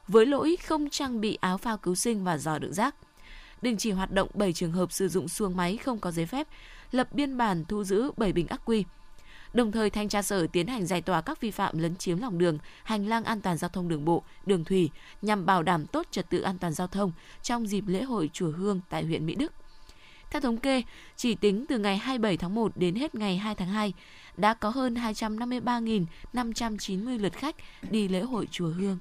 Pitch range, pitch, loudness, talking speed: 180-230 Hz, 200 Hz, -29 LUFS, 230 wpm